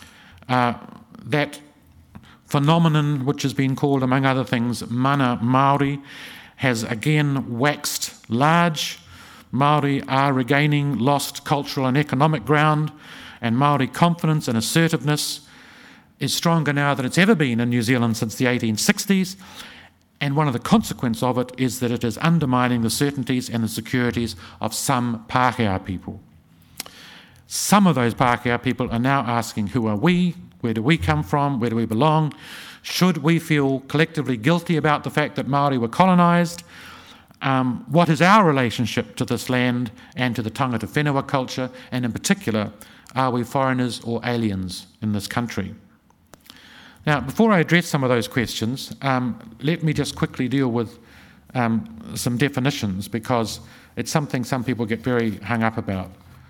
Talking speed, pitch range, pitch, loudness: 155 wpm, 120-150 Hz, 130 Hz, -21 LUFS